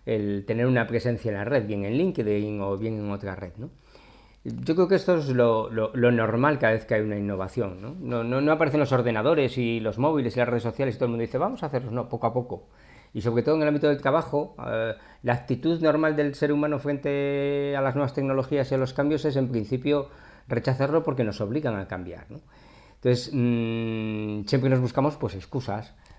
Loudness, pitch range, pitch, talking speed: -26 LUFS, 110-145 Hz, 125 Hz, 225 wpm